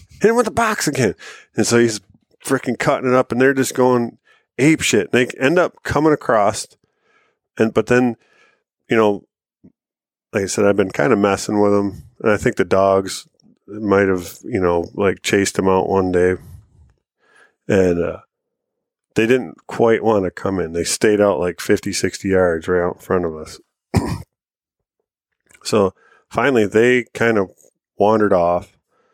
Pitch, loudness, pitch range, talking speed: 100 Hz, -17 LUFS, 95-120 Hz, 175 wpm